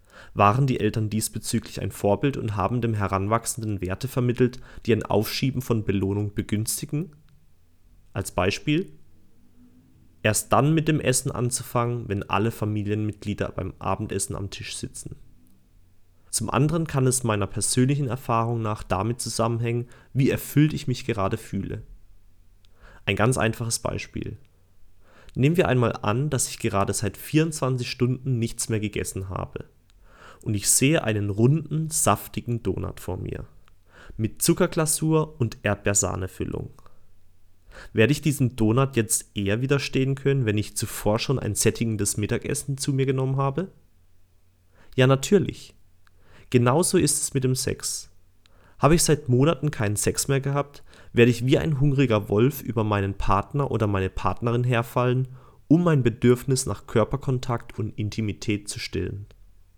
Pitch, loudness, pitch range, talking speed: 115 Hz, -24 LUFS, 100-130 Hz, 140 wpm